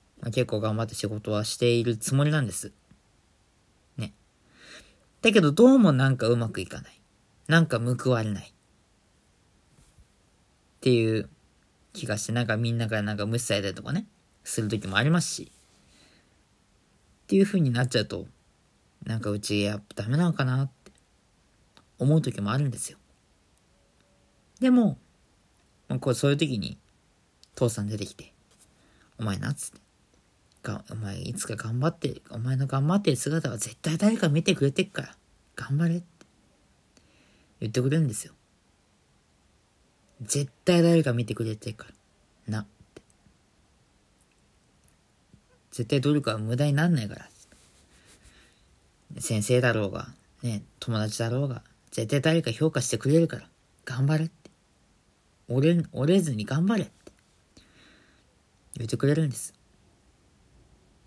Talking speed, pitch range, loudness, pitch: 270 characters per minute, 105-150 Hz, -26 LUFS, 120 Hz